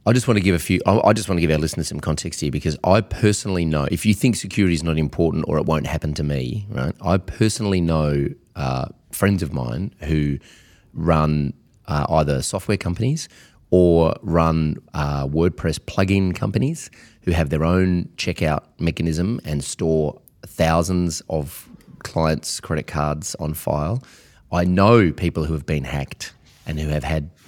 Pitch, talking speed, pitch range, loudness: 85 Hz, 175 wpm, 75-95 Hz, -21 LUFS